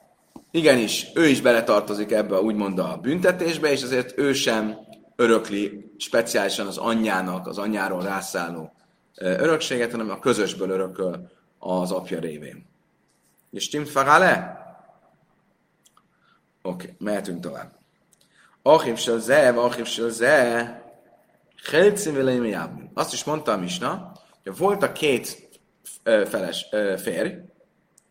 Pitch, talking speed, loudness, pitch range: 115 Hz, 110 wpm, -22 LUFS, 100-125 Hz